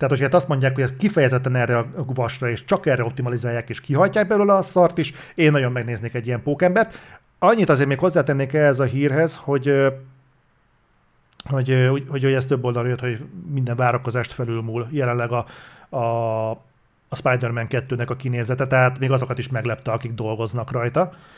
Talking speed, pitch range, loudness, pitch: 175 wpm, 120-145 Hz, -21 LUFS, 130 Hz